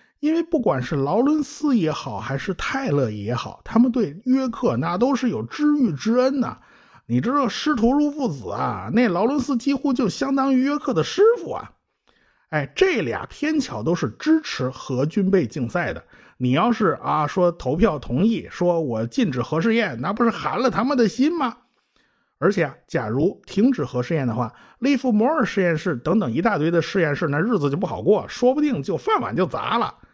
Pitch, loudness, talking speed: 230 Hz, -22 LUFS, 280 characters per minute